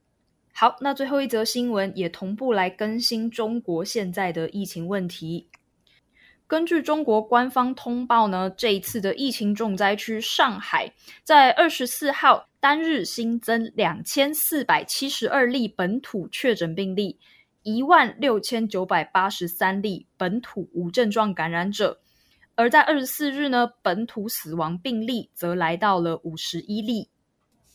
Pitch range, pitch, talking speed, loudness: 190-255 Hz, 225 Hz, 225 characters per minute, -23 LUFS